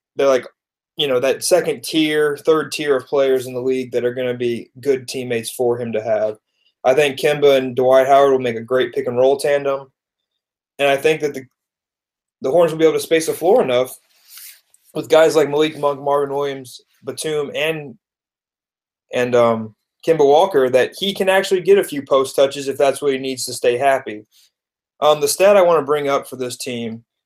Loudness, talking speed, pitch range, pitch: -17 LUFS, 210 wpm, 125-155 Hz, 140 Hz